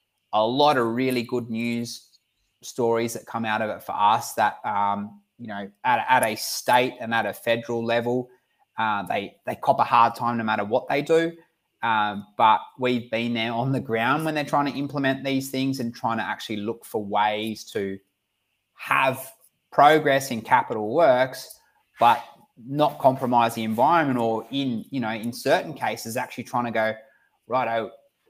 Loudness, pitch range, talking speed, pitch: -24 LUFS, 110-135 Hz, 180 wpm, 120 Hz